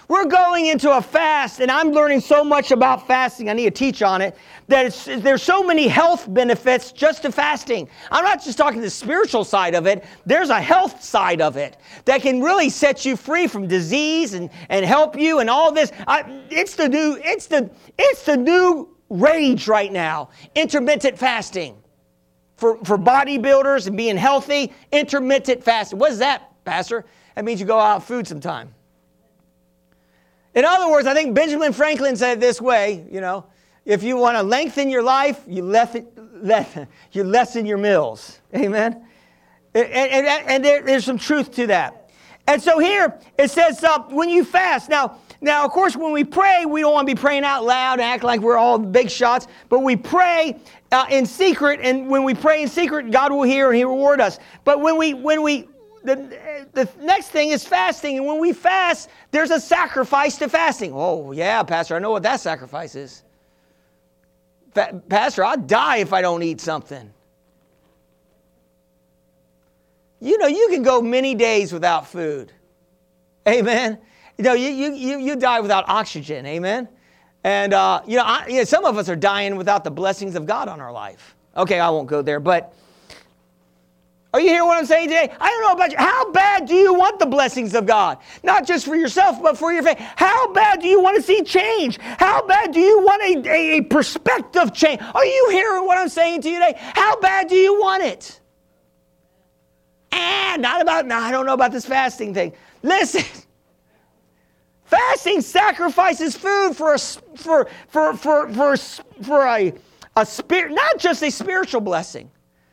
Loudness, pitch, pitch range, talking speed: -18 LUFS, 265 Hz, 195-310 Hz, 190 wpm